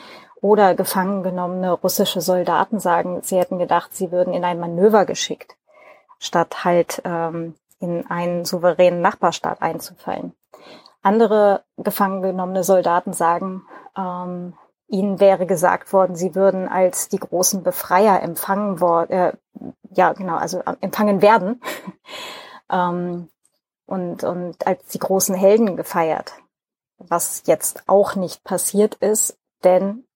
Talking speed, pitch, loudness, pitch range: 120 wpm, 185 Hz, -19 LUFS, 180-195 Hz